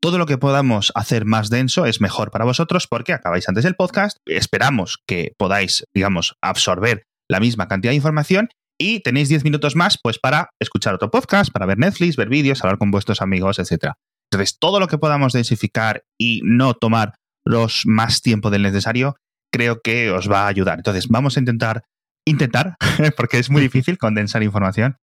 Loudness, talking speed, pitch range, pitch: -18 LUFS, 185 wpm, 105-150 Hz, 120 Hz